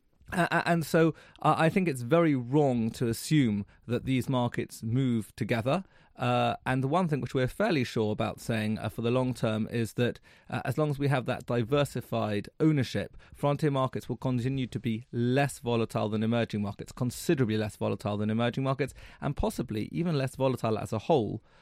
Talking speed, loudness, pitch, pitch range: 190 wpm, -29 LUFS, 125 Hz, 110-135 Hz